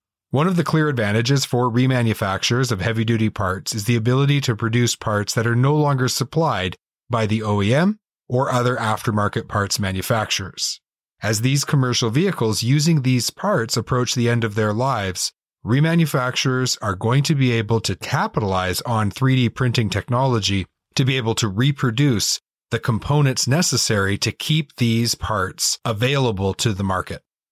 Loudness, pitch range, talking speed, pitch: -20 LUFS, 110-135 Hz, 155 wpm, 120 Hz